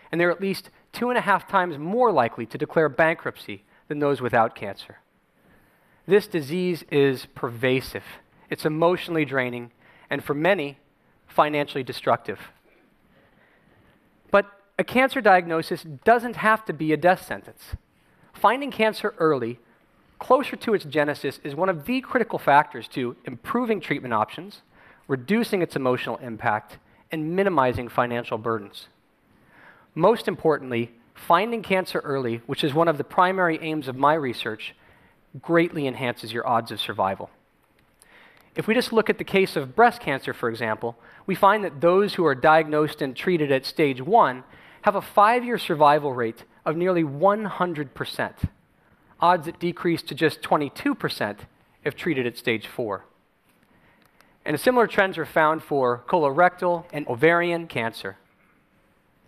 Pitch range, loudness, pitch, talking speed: 135-185 Hz, -23 LUFS, 160 Hz, 145 wpm